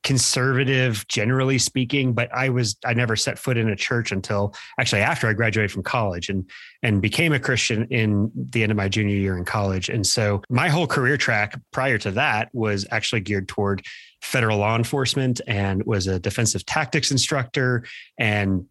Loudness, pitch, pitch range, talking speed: -22 LUFS, 115 Hz, 105-130 Hz, 185 wpm